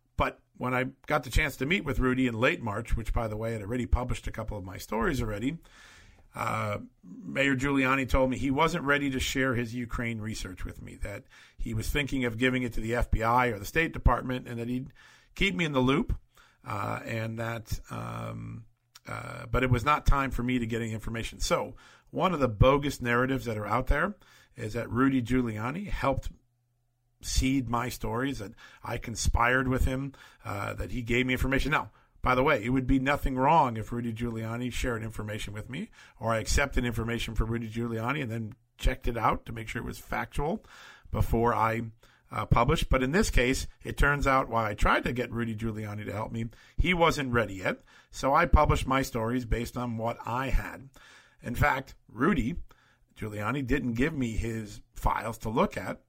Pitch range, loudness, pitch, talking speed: 115-130 Hz, -29 LUFS, 120 Hz, 200 wpm